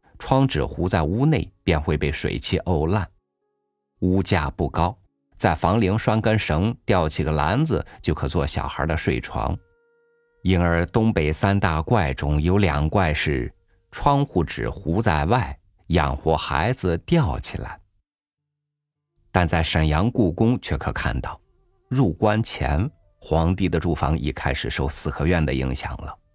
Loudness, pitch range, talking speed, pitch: -22 LUFS, 80-120 Hz, 205 characters per minute, 95 Hz